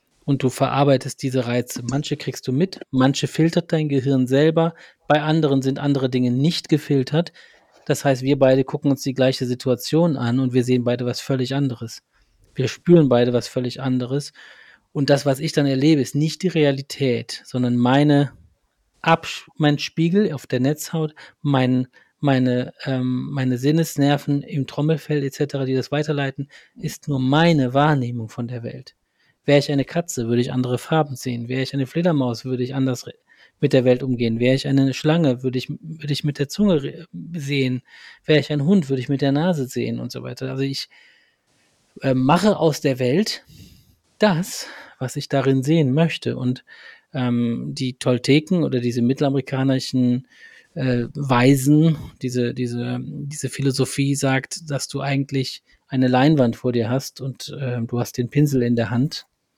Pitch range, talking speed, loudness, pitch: 125-150 Hz, 170 wpm, -21 LUFS, 135 Hz